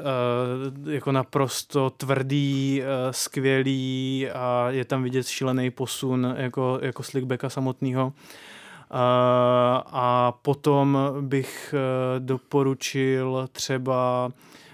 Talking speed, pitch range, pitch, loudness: 75 wpm, 125-135 Hz, 130 Hz, -25 LUFS